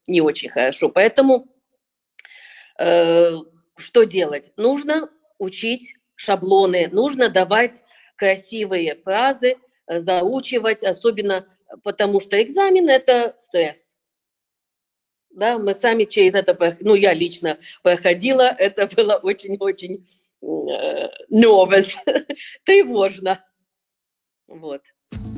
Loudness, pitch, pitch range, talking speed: -18 LUFS, 200 Hz, 185-245 Hz, 85 wpm